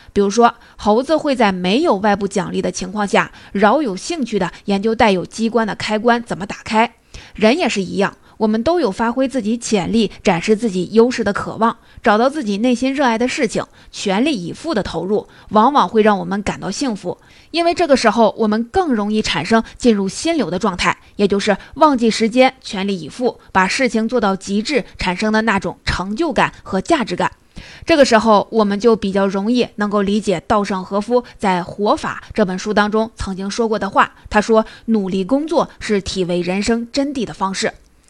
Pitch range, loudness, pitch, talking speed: 195-235 Hz, -17 LUFS, 215 Hz, 295 characters per minute